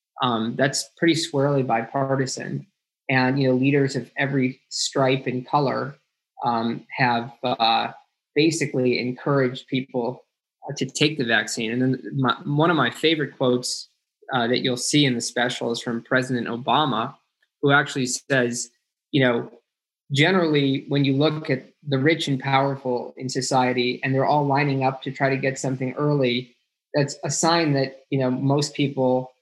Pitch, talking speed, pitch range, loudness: 135 Hz, 160 wpm, 125-140 Hz, -22 LUFS